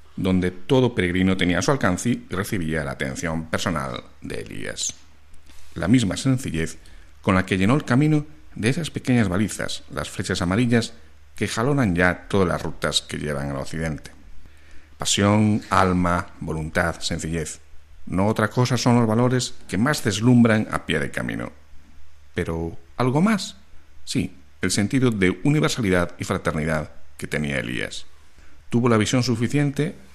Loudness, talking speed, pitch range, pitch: -22 LUFS, 145 wpm, 80-120 Hz, 90 Hz